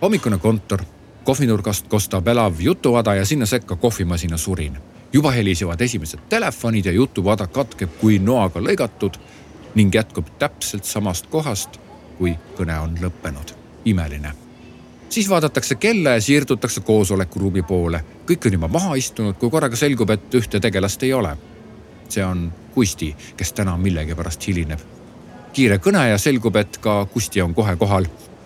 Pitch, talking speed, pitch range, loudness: 105 Hz, 145 wpm, 90-120 Hz, -19 LUFS